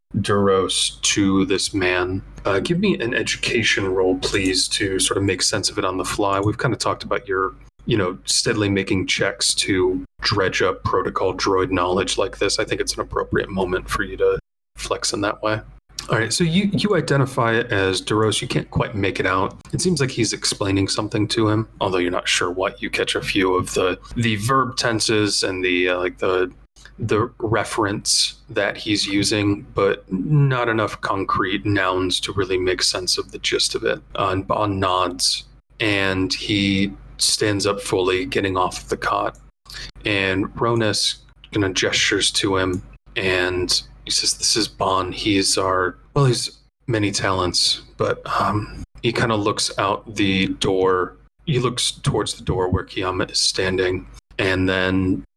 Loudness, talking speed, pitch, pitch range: -20 LUFS, 180 wpm, 100 Hz, 95-120 Hz